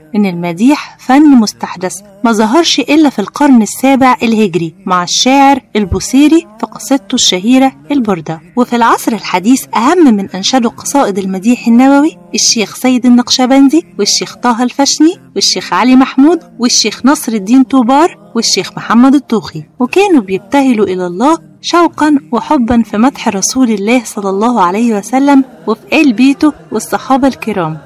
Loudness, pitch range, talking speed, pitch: -9 LUFS, 205-275 Hz, 135 wpm, 245 Hz